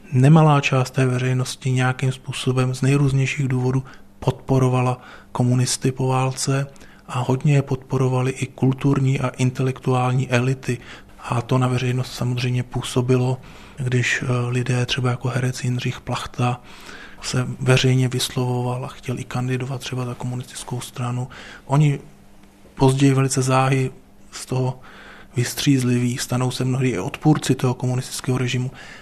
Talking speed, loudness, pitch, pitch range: 125 wpm, -21 LUFS, 130 Hz, 125-130 Hz